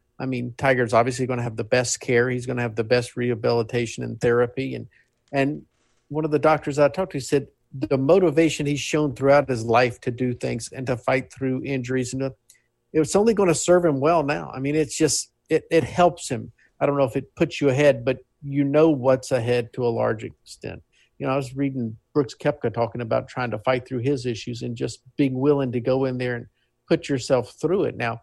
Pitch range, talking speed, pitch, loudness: 120-145 Hz, 225 wpm, 130 Hz, -23 LUFS